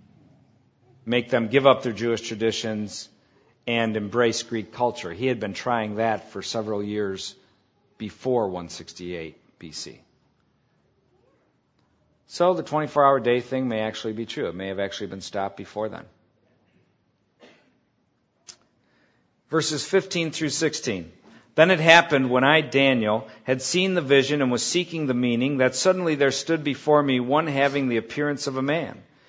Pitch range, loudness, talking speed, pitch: 110-140 Hz, -23 LUFS, 150 wpm, 125 Hz